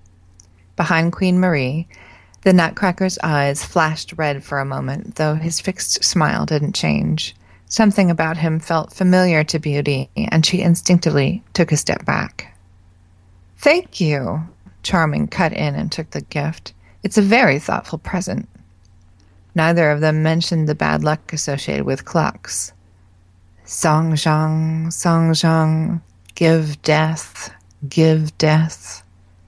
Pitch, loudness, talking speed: 155 Hz, -18 LUFS, 130 wpm